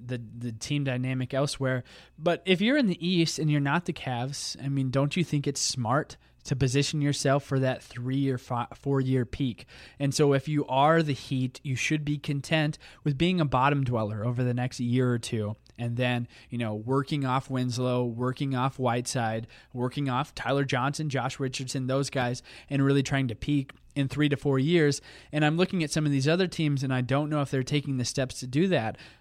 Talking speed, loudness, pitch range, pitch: 215 wpm, -28 LUFS, 125-145 Hz, 135 Hz